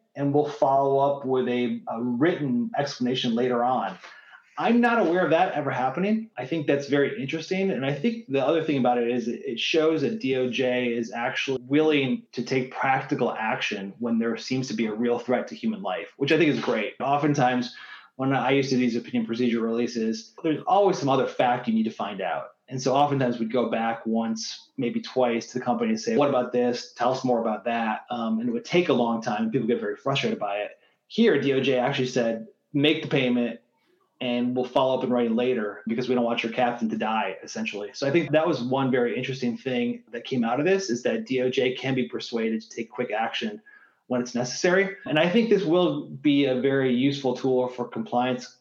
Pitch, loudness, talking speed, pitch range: 130 Hz, -25 LUFS, 220 wpm, 120-150 Hz